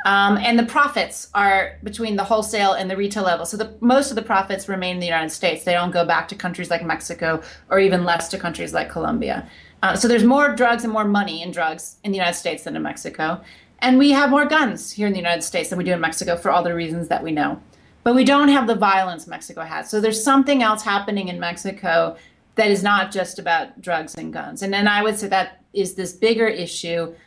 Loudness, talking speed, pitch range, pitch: -20 LUFS, 240 wpm, 175-220 Hz, 195 Hz